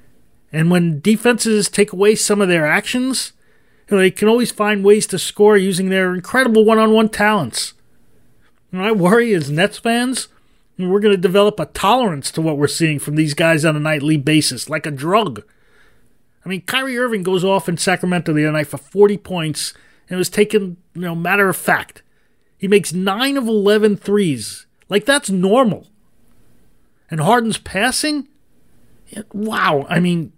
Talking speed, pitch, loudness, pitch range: 180 wpm, 190 Hz, -16 LUFS, 160-215 Hz